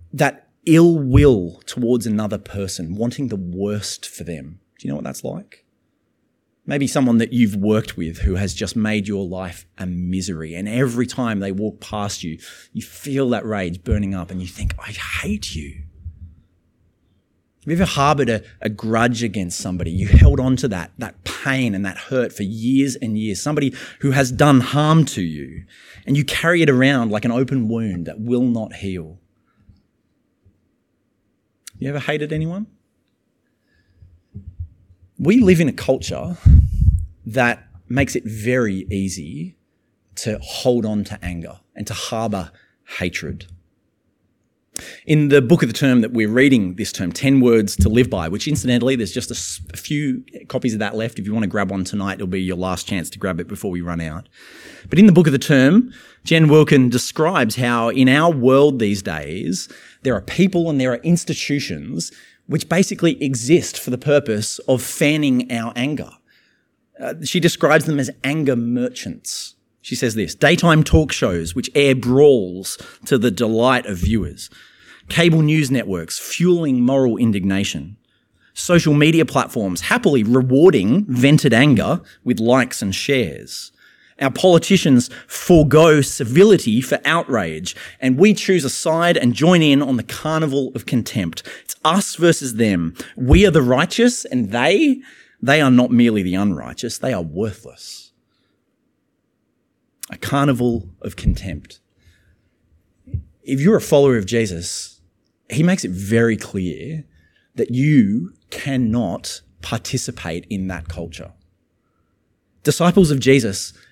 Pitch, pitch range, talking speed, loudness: 115 Hz, 95-140 Hz, 155 wpm, -18 LUFS